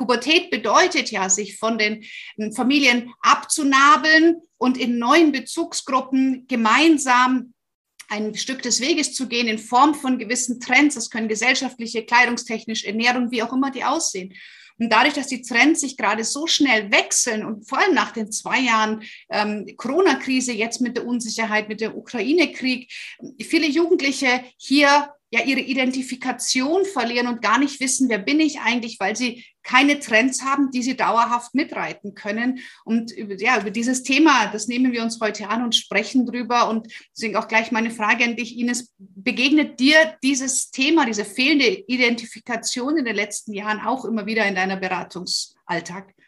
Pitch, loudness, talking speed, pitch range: 245 Hz, -19 LUFS, 165 wpm, 220-270 Hz